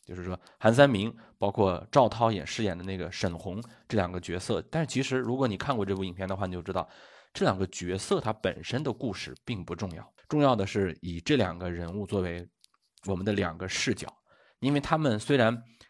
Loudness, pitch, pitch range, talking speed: -29 LUFS, 100 Hz, 90-115 Hz, 310 characters per minute